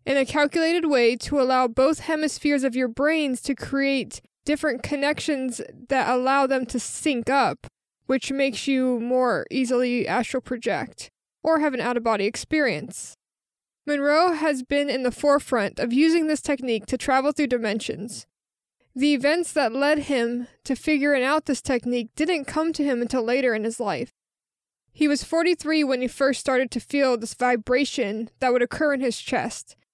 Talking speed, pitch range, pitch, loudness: 170 wpm, 250-295 Hz, 270 Hz, -23 LUFS